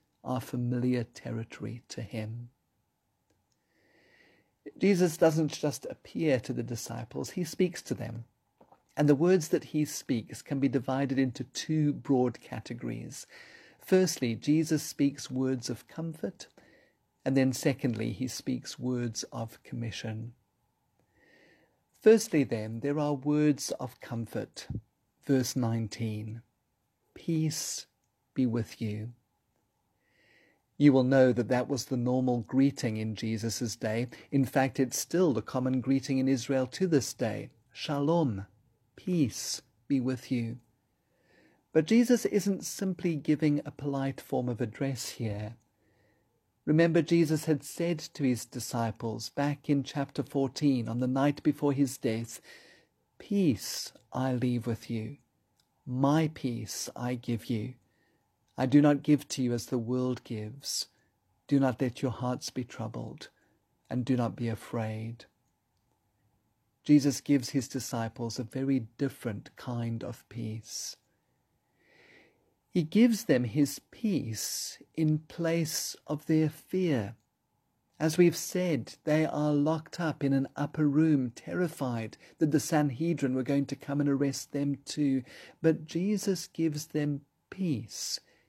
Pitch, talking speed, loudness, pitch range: 130 Hz, 130 wpm, -30 LUFS, 120-150 Hz